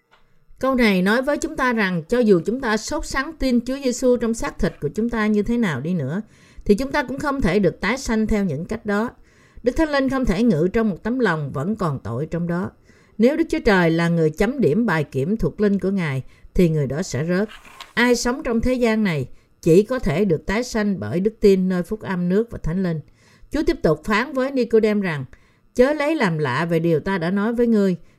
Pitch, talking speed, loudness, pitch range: 210 Hz, 245 wpm, -21 LUFS, 170-240 Hz